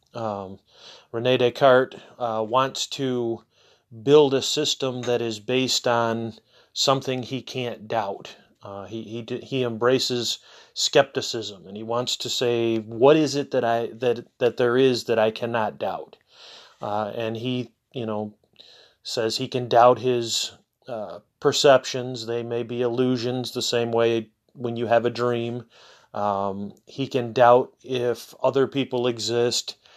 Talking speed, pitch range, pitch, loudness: 145 wpm, 115-130 Hz, 120 Hz, -23 LUFS